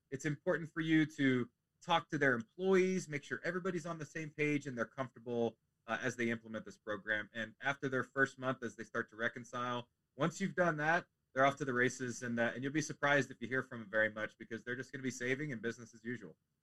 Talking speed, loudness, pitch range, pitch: 245 wpm, -37 LUFS, 115-150 Hz, 130 Hz